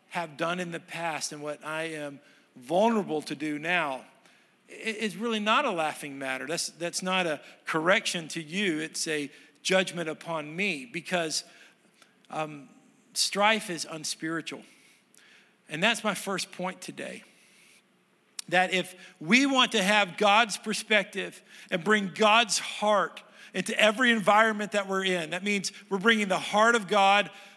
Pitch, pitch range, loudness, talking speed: 190 Hz, 165-210 Hz, -27 LUFS, 150 wpm